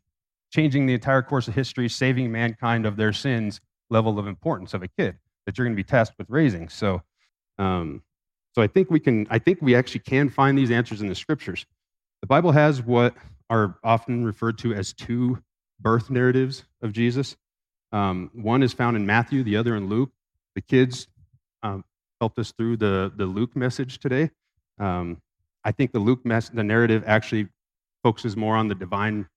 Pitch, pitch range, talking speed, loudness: 115 Hz, 105-130 Hz, 185 wpm, -23 LUFS